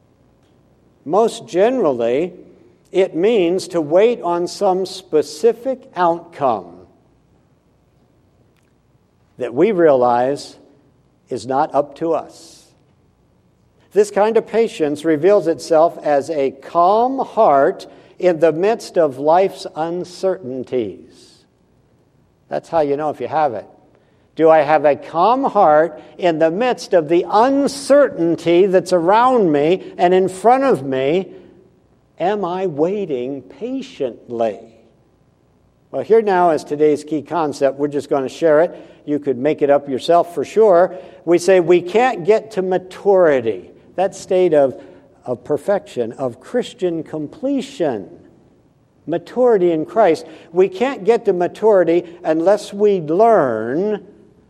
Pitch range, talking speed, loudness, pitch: 150-200 Hz, 125 wpm, -17 LUFS, 175 Hz